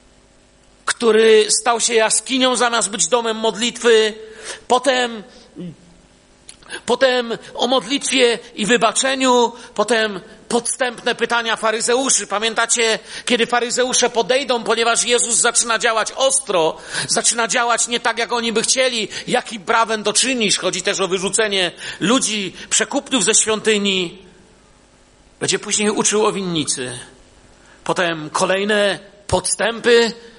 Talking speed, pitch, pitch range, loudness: 110 wpm, 230 Hz, 210-240 Hz, -17 LUFS